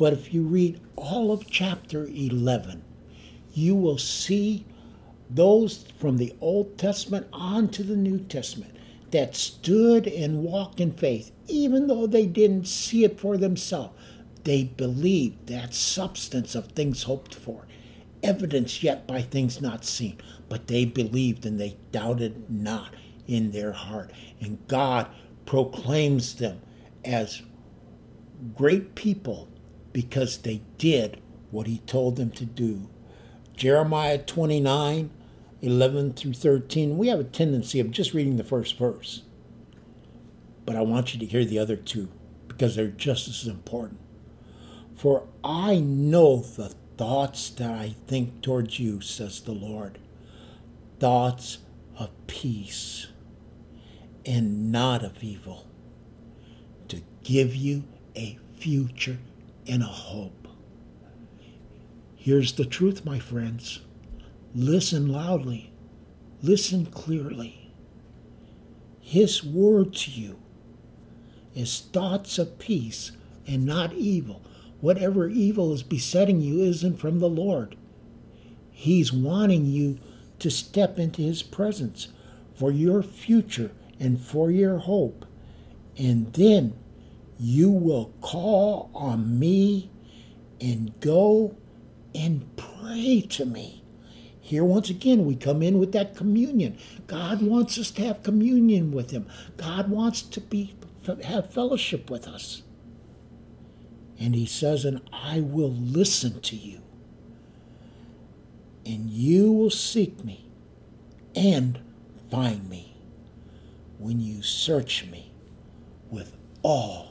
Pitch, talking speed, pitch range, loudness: 135 Hz, 120 wpm, 115-185 Hz, -25 LUFS